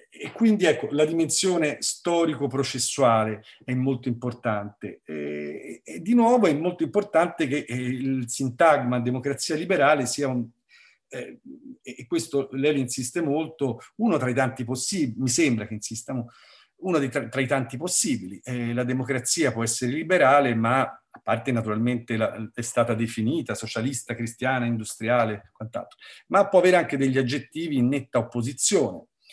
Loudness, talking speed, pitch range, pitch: -24 LUFS, 145 wpm, 120-155 Hz, 130 Hz